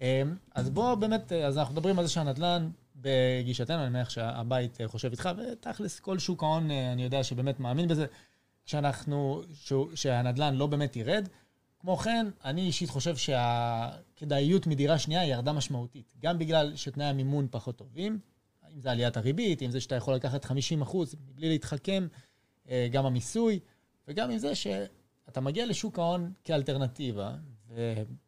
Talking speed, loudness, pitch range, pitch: 150 wpm, -31 LUFS, 125-170 Hz, 140 Hz